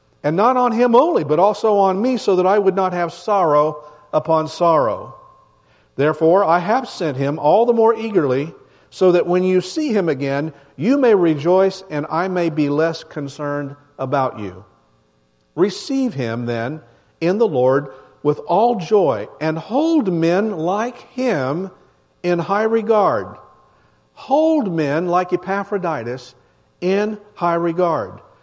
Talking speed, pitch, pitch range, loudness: 145 wpm, 170 Hz, 145-205 Hz, -18 LUFS